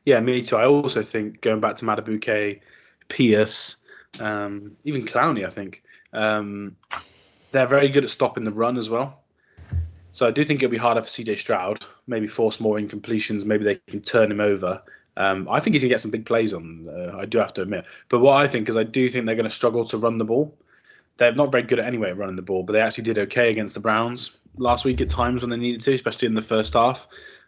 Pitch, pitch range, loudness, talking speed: 110 Hz, 105-120 Hz, -22 LUFS, 235 wpm